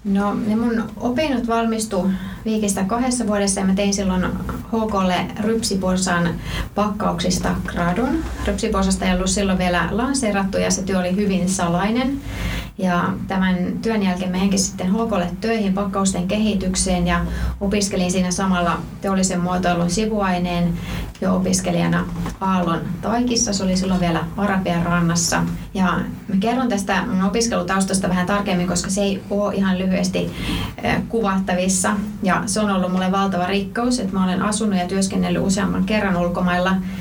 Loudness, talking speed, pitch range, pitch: -20 LUFS, 140 wpm, 180-205 Hz, 190 Hz